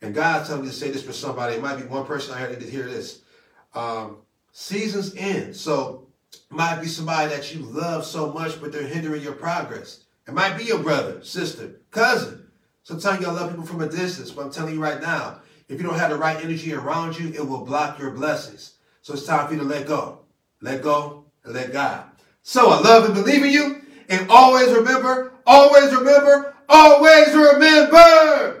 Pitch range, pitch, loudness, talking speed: 145-225 Hz, 160 Hz, -16 LUFS, 205 wpm